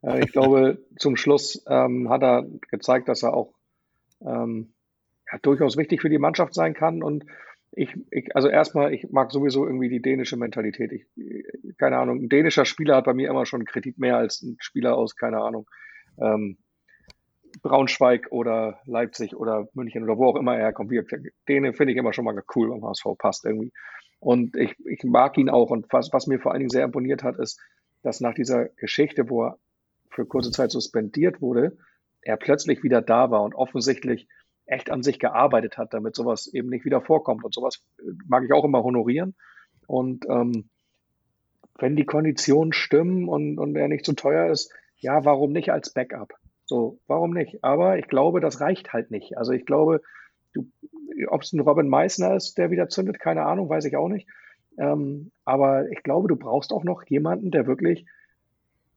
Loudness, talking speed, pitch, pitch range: -23 LUFS, 190 wpm, 135 Hz, 120-150 Hz